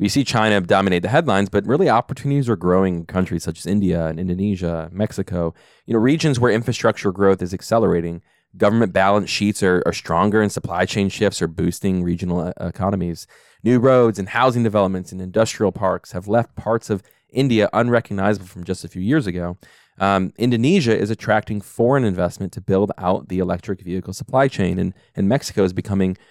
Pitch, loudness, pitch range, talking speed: 100 Hz, -19 LUFS, 90-115 Hz, 180 wpm